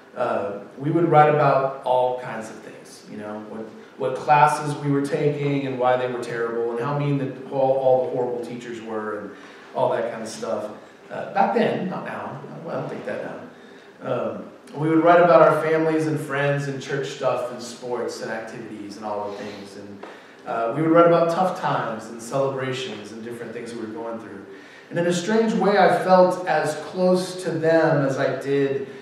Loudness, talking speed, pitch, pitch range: -22 LUFS, 205 wpm, 135 Hz, 115-155 Hz